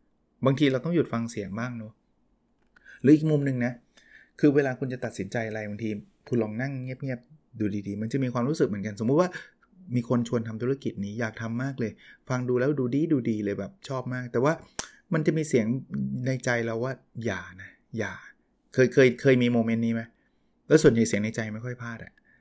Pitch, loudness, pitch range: 120 Hz, -27 LUFS, 115-135 Hz